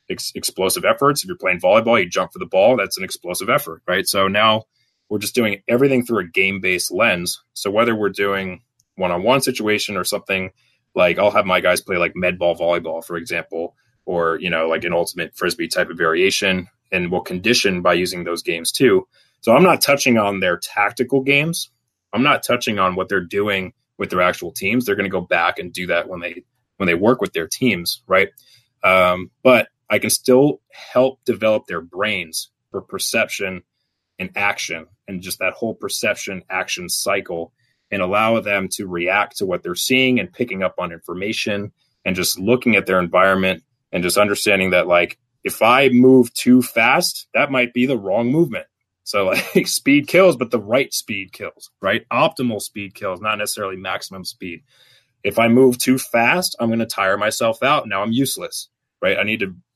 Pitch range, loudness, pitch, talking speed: 90-125 Hz, -18 LUFS, 105 Hz, 190 wpm